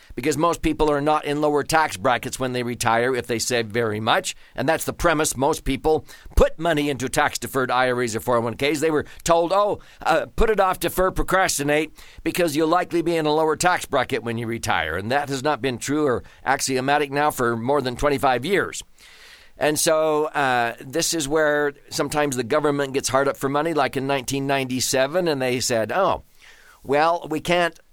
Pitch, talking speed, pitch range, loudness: 145 Hz, 195 wpm, 130-155 Hz, -22 LUFS